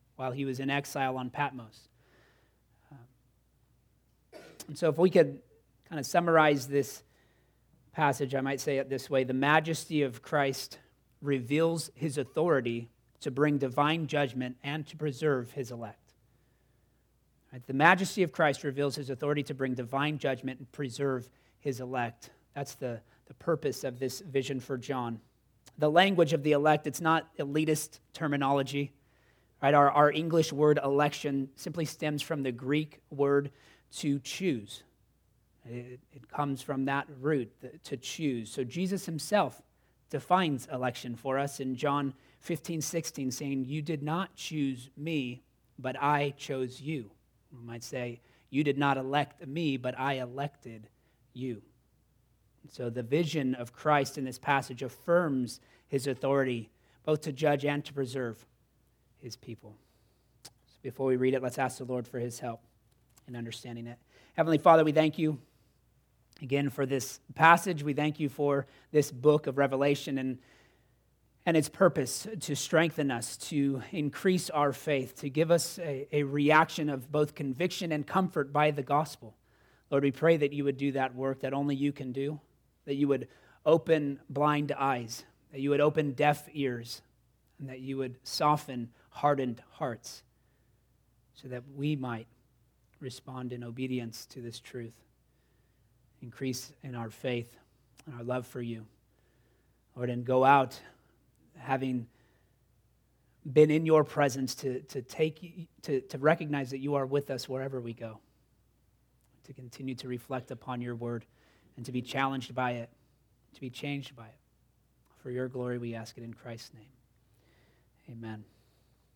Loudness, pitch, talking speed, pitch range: -31 LUFS, 135 Hz, 155 wpm, 125-145 Hz